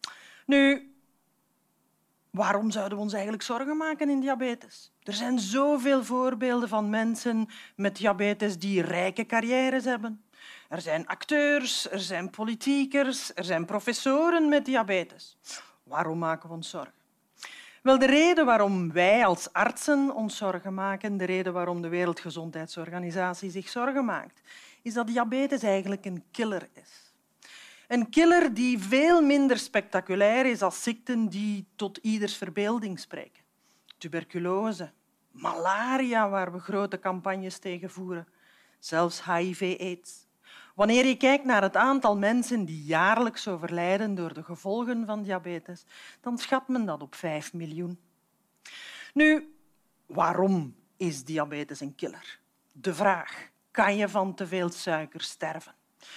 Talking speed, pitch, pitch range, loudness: 130 wpm, 205 Hz, 180-250 Hz, -27 LUFS